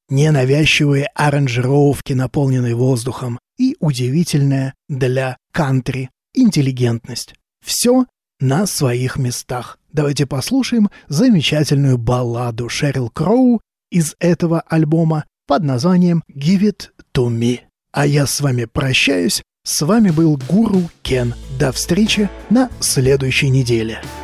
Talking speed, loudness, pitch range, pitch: 105 wpm, -16 LUFS, 130-170 Hz, 140 Hz